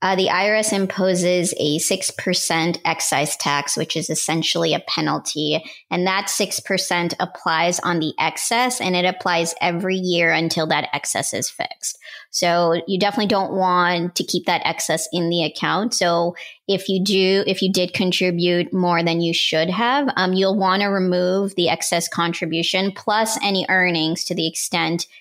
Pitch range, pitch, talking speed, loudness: 170-190 Hz, 180 Hz, 165 wpm, -19 LUFS